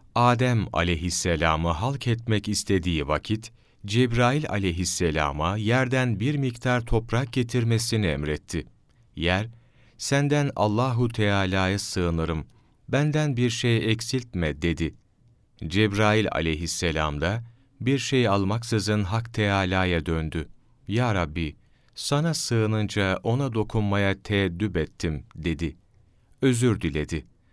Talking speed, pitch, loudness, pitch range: 95 wpm, 105 Hz, -25 LUFS, 90-120 Hz